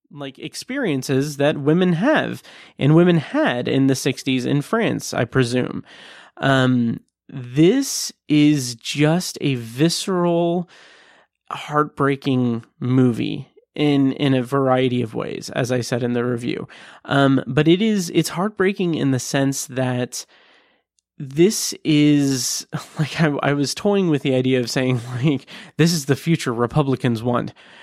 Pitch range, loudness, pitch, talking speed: 130-165 Hz, -20 LUFS, 140 Hz, 140 wpm